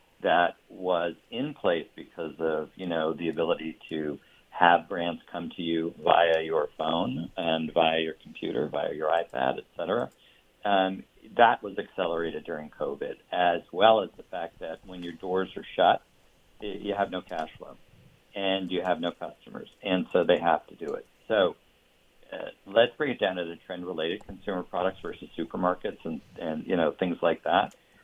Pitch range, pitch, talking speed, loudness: 80-90 Hz, 85 Hz, 180 wpm, -28 LUFS